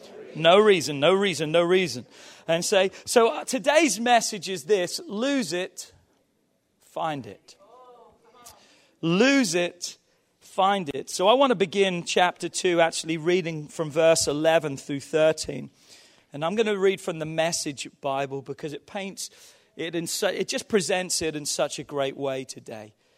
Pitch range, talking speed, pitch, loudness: 155-210 Hz, 155 wpm, 175 Hz, -24 LUFS